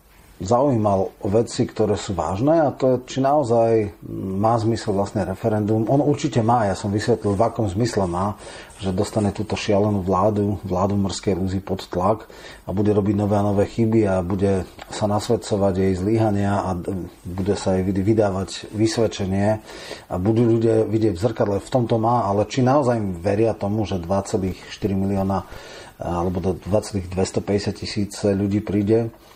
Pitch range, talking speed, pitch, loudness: 95-110 Hz, 160 wpm, 105 Hz, -21 LUFS